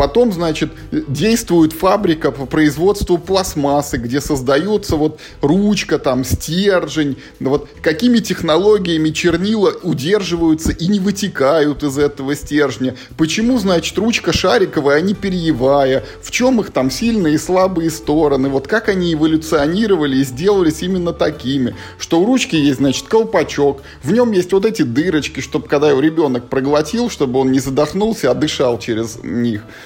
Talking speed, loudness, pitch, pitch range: 145 wpm, -15 LUFS, 155 Hz, 140-195 Hz